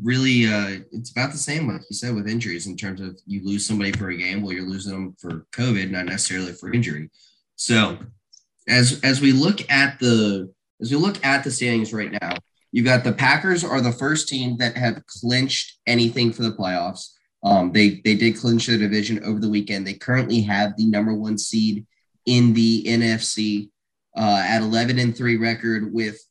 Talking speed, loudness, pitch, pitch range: 200 wpm, -21 LUFS, 115 Hz, 105-120 Hz